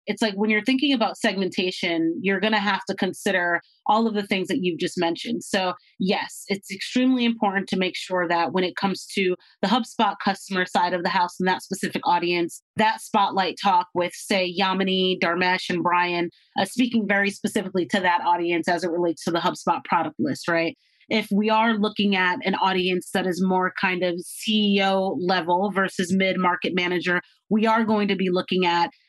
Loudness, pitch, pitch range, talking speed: -23 LUFS, 190 Hz, 180-205 Hz, 195 wpm